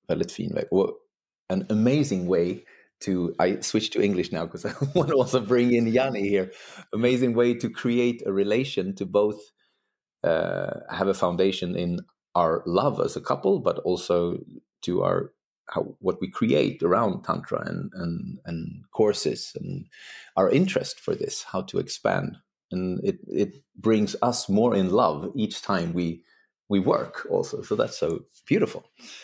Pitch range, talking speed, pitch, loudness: 90-130 Hz, 160 wpm, 105 Hz, -26 LUFS